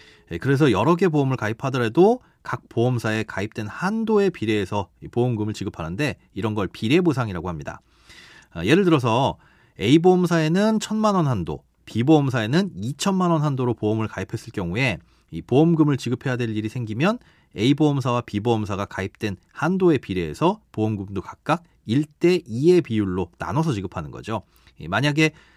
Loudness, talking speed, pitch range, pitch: -22 LUFS, 350 characters per minute, 105-160 Hz, 125 Hz